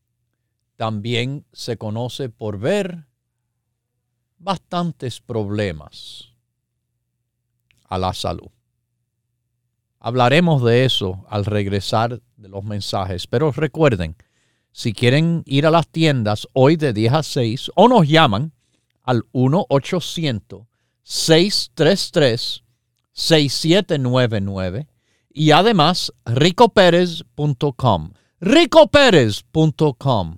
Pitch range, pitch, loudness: 115-155 Hz, 120 Hz, -17 LUFS